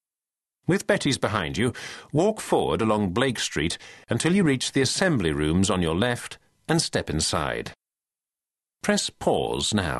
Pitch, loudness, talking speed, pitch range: 115 Hz, -24 LUFS, 145 wpm, 90-140 Hz